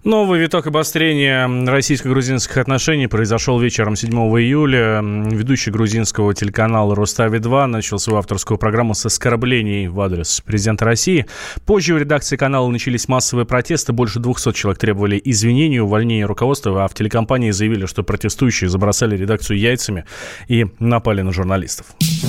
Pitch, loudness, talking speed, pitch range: 115 Hz, -16 LUFS, 135 wpm, 105-130 Hz